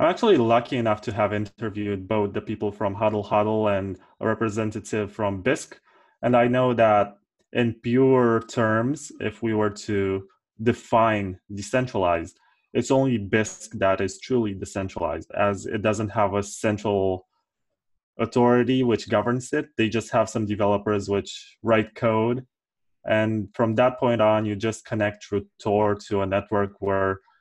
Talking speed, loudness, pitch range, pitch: 155 wpm, -24 LUFS, 100-115 Hz, 110 Hz